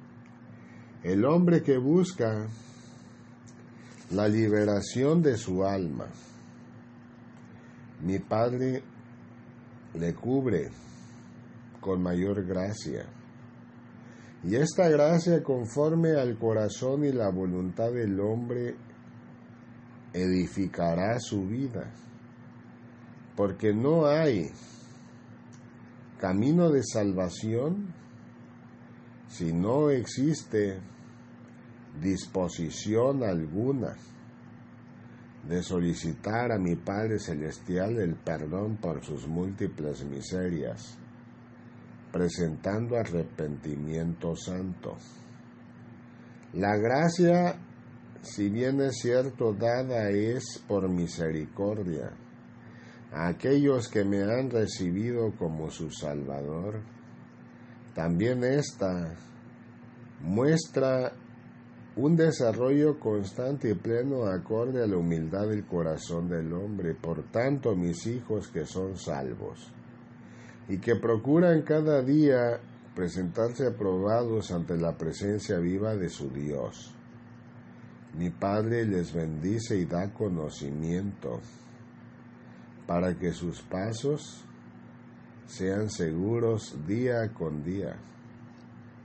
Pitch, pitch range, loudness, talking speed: 105 Hz, 85-120 Hz, -29 LUFS, 85 wpm